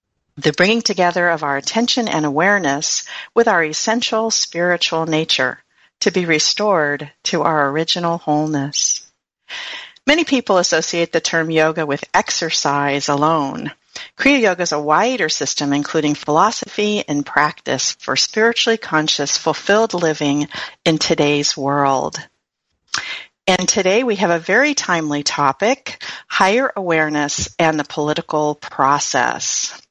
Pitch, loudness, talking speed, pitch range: 160 Hz, -17 LUFS, 120 wpm, 150-200 Hz